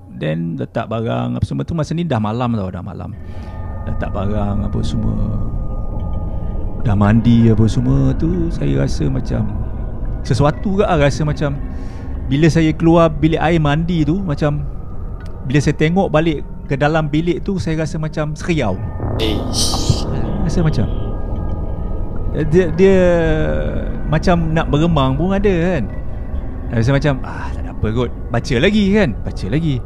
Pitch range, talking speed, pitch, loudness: 95-155 Hz, 145 wpm, 115 Hz, -17 LUFS